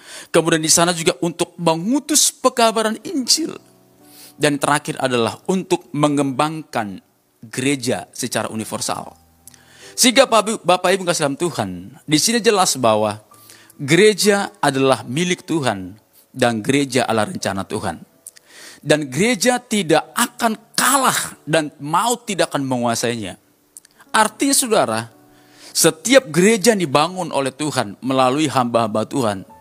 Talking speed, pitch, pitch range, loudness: 115 wpm, 155 Hz, 125-200 Hz, -18 LUFS